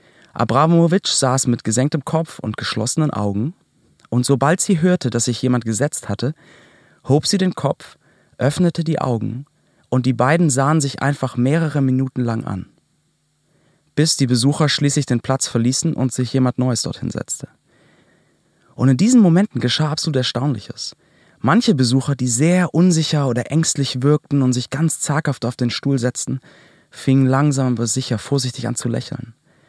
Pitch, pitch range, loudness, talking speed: 135 Hz, 125-155 Hz, -18 LUFS, 160 wpm